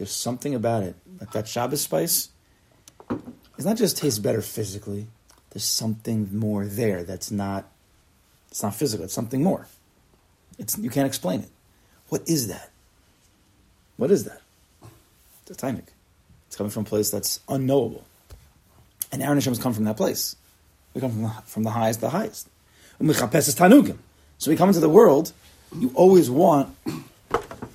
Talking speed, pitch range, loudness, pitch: 160 wpm, 100-125 Hz, -23 LUFS, 110 Hz